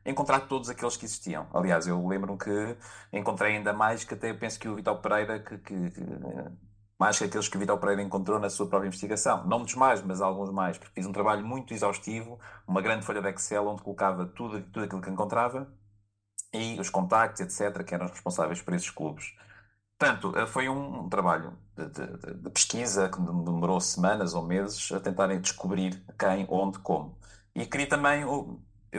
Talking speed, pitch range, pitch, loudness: 190 wpm, 95-110 Hz, 100 Hz, -30 LUFS